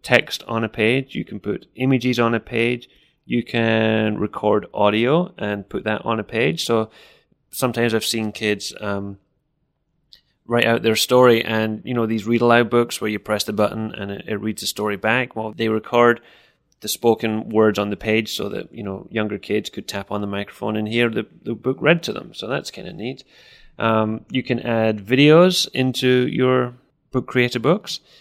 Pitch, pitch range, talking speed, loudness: 115 Hz, 110-125 Hz, 200 wpm, -20 LUFS